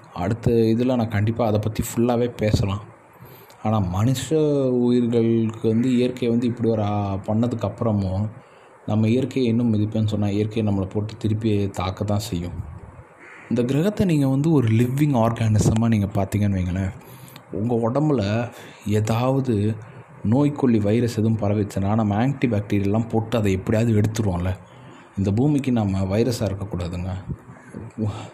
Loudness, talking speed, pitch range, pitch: -22 LUFS, 120 wpm, 105-120 Hz, 110 Hz